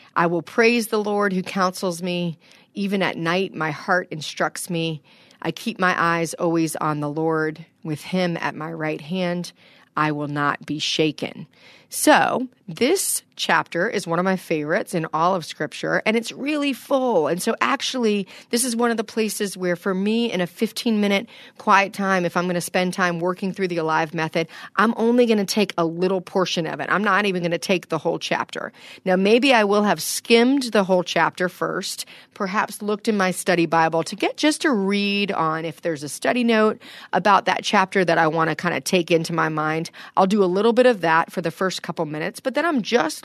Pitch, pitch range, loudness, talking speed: 185 Hz, 165-215 Hz, -21 LUFS, 215 wpm